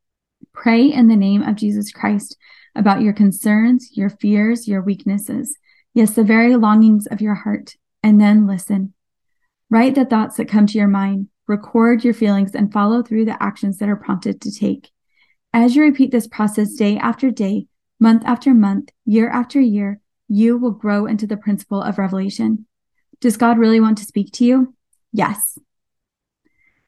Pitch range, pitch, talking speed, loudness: 205-235 Hz, 220 Hz, 170 wpm, -16 LUFS